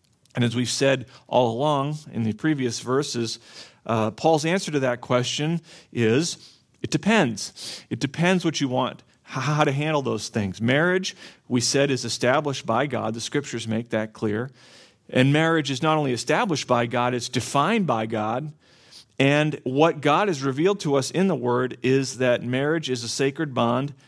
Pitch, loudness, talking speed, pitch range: 135 Hz, -23 LUFS, 175 wpm, 120-150 Hz